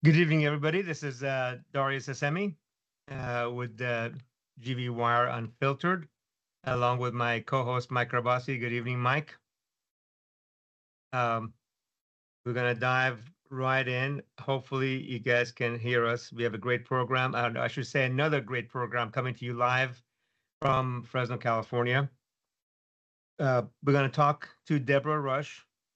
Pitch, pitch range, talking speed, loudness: 125 Hz, 120-135 Hz, 150 wpm, -30 LUFS